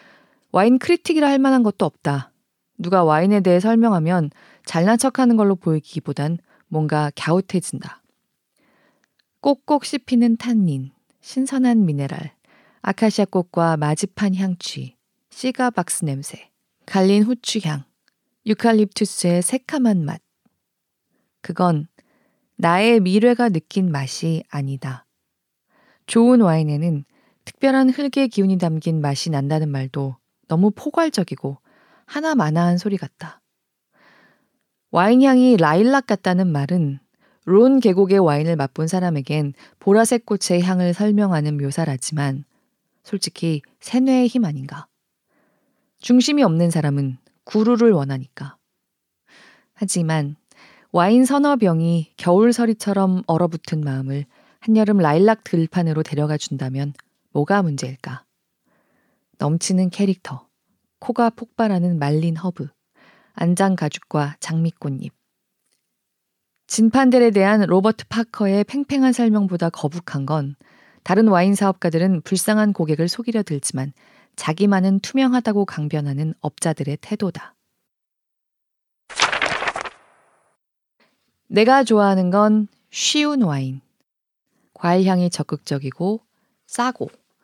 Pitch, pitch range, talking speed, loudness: 185 Hz, 155-225 Hz, 250 characters per minute, -19 LUFS